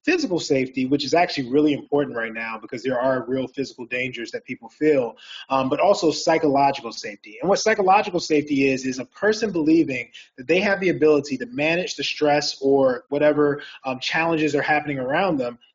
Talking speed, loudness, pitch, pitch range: 185 wpm, -21 LUFS, 145 Hz, 130-160 Hz